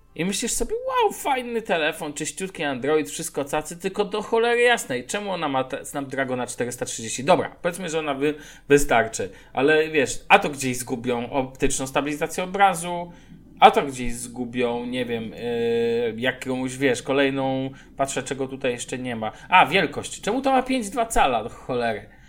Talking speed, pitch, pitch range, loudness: 155 wpm, 150 Hz, 130-195 Hz, -23 LUFS